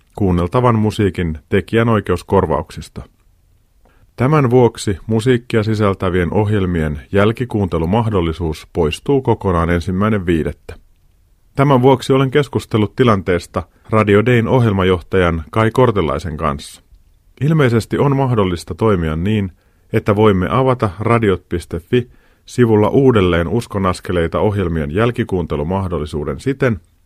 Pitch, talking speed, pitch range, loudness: 100 Hz, 85 wpm, 85-115 Hz, -16 LUFS